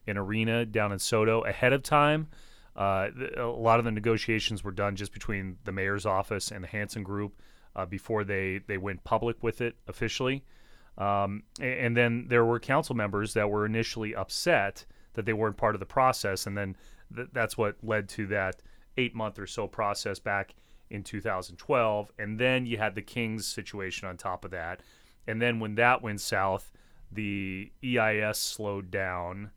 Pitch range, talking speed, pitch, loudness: 100-115 Hz, 185 wpm, 105 Hz, -30 LUFS